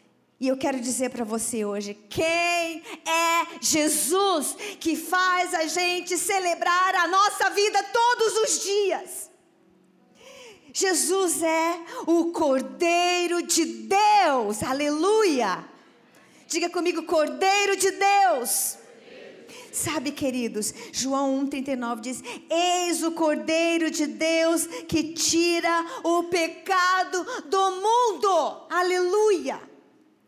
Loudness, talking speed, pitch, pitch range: -23 LUFS, 100 wpm, 335 Hz, 305-375 Hz